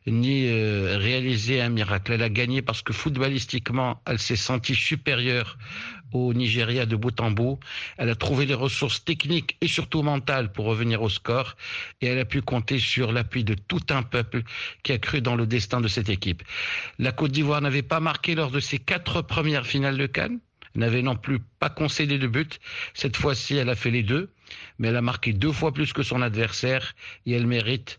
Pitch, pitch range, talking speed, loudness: 125 Hz, 115-140 Hz, 205 wpm, -25 LUFS